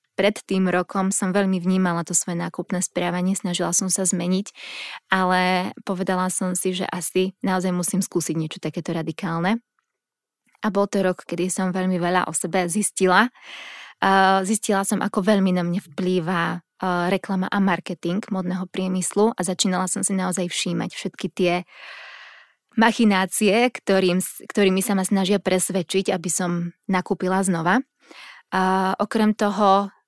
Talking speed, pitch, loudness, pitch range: 140 wpm, 185 Hz, -22 LUFS, 180-200 Hz